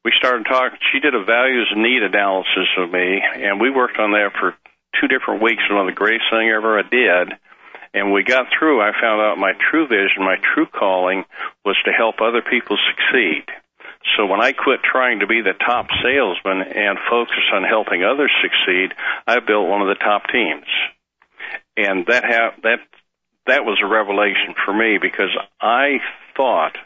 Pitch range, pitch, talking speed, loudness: 95-115 Hz, 105 Hz, 190 wpm, -16 LUFS